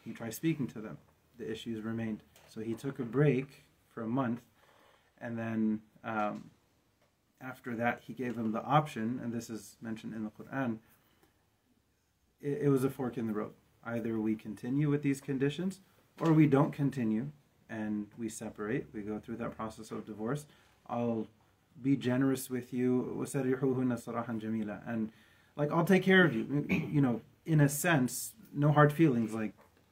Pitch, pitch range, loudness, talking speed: 120 Hz, 110-140 Hz, -33 LUFS, 165 wpm